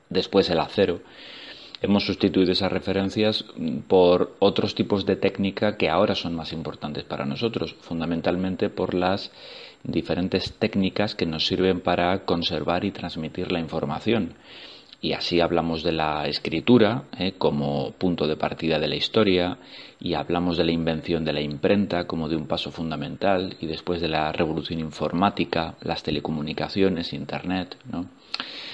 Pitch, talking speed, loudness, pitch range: 90 Hz, 145 wpm, -24 LUFS, 80-95 Hz